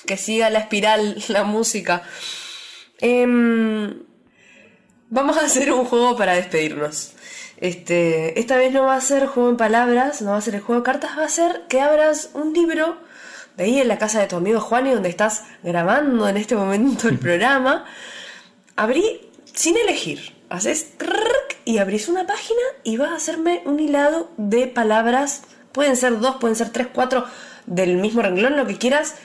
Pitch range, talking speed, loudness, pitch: 215-295 Hz, 175 wpm, -19 LUFS, 250 Hz